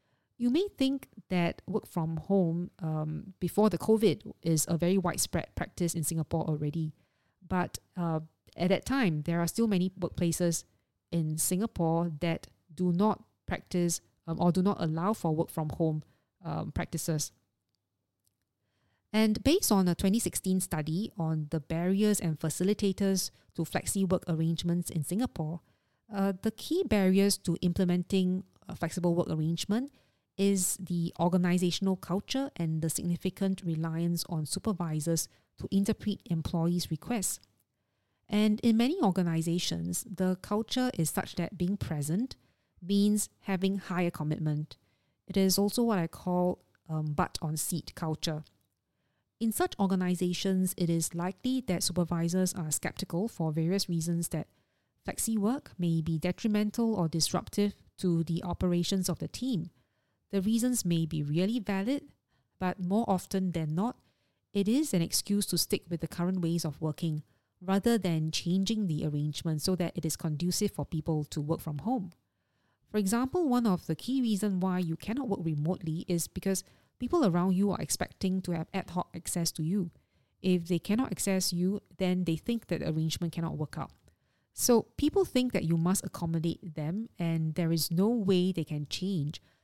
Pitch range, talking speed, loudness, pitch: 160-195 Hz, 155 wpm, -31 LUFS, 175 Hz